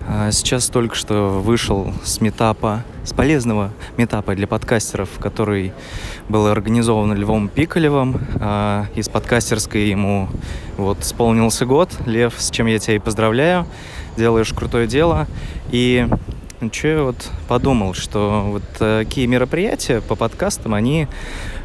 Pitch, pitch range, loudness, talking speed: 110 Hz, 100-120 Hz, -18 LUFS, 120 wpm